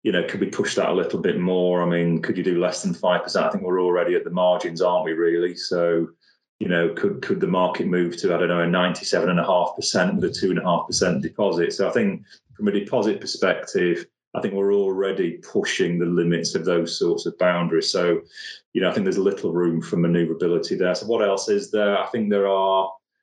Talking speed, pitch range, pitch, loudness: 245 wpm, 85-95 Hz, 90 Hz, -22 LUFS